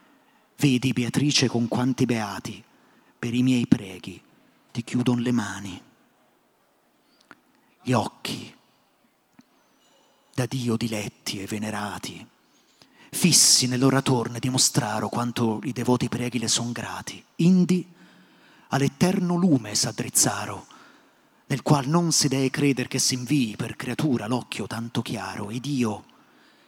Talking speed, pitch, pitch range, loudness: 110 wpm, 125 Hz, 115-140 Hz, -24 LUFS